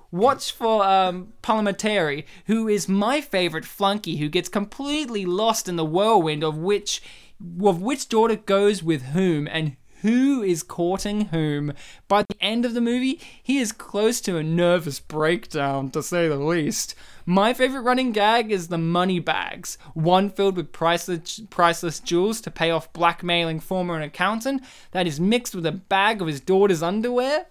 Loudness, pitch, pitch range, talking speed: -23 LUFS, 190 Hz, 170-215 Hz, 165 wpm